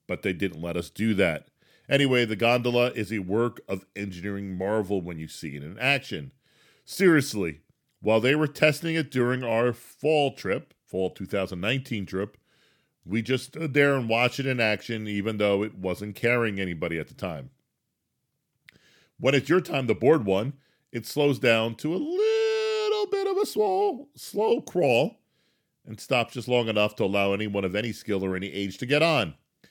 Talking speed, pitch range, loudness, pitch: 180 wpm, 100-145 Hz, -26 LUFS, 115 Hz